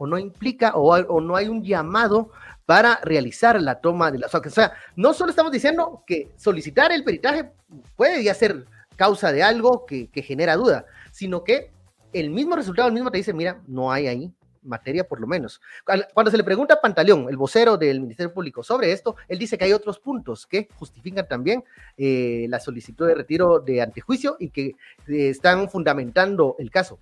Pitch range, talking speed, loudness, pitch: 145-225 Hz, 195 wpm, -21 LUFS, 185 Hz